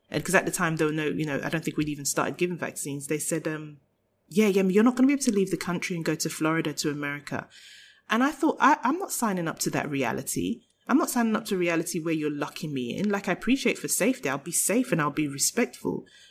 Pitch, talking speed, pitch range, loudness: 170 Hz, 270 wpm, 150-215 Hz, -26 LUFS